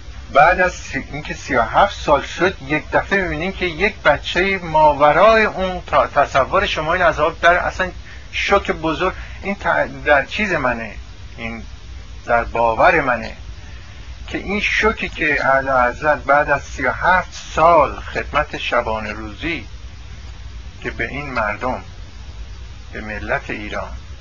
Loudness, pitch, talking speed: -17 LUFS, 125 Hz, 125 wpm